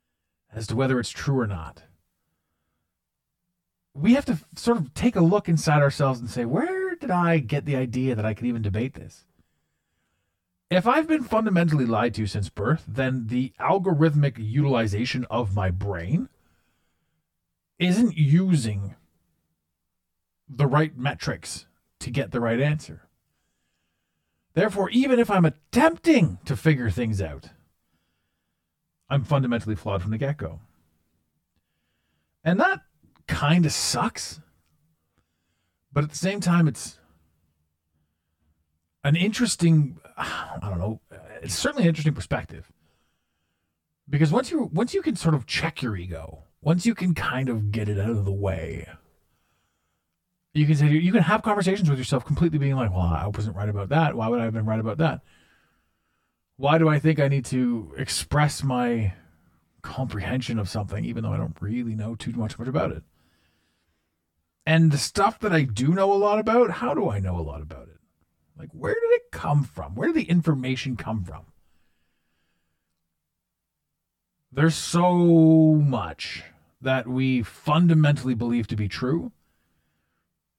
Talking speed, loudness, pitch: 150 wpm, -24 LUFS, 105 Hz